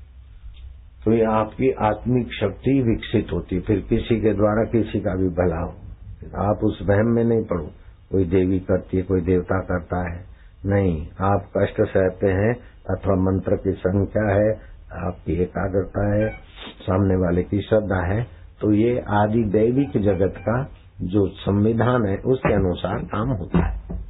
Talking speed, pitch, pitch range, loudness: 160 wpm, 95 Hz, 90-110 Hz, -22 LUFS